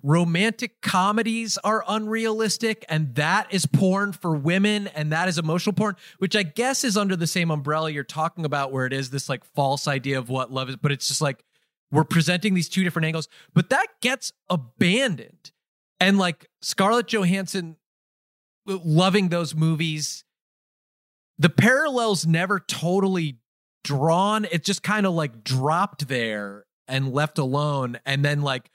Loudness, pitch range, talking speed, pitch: -23 LUFS, 145-200 Hz, 160 wpm, 170 Hz